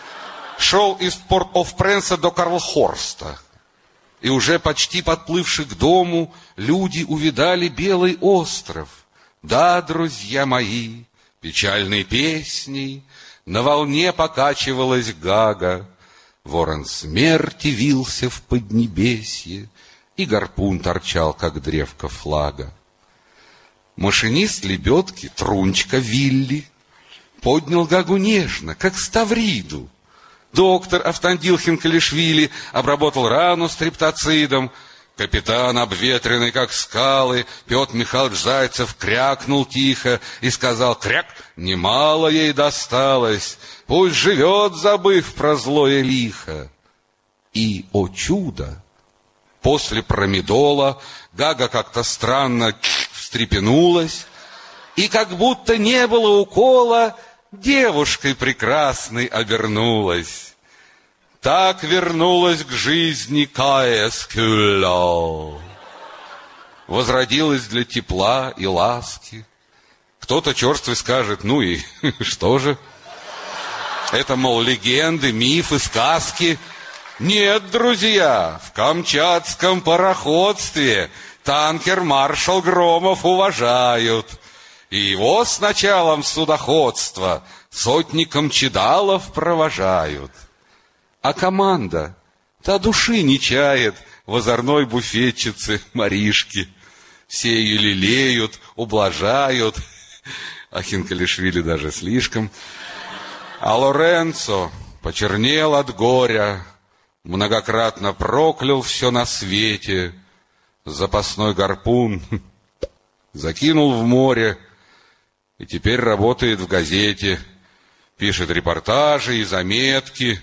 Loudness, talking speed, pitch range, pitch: -17 LUFS, 85 wpm, 100-160 Hz, 125 Hz